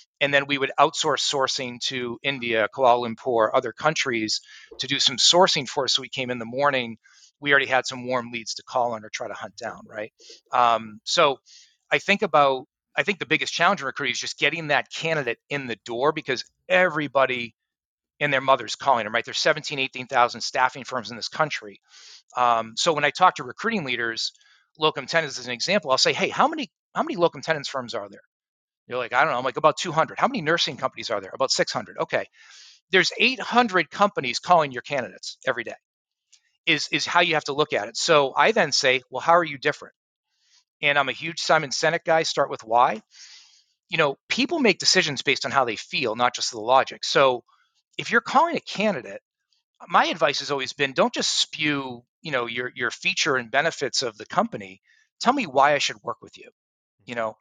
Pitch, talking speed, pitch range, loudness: 140 Hz, 210 wpm, 125-160 Hz, -23 LUFS